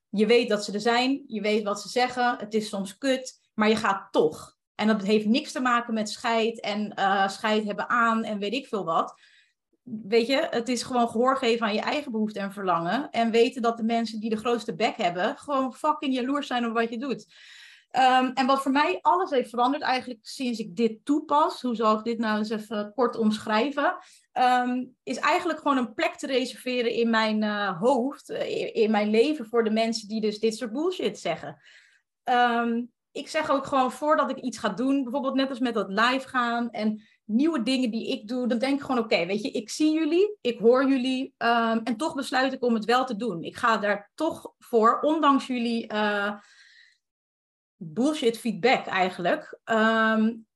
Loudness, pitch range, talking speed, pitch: -25 LUFS, 220-265 Hz, 205 wpm, 235 Hz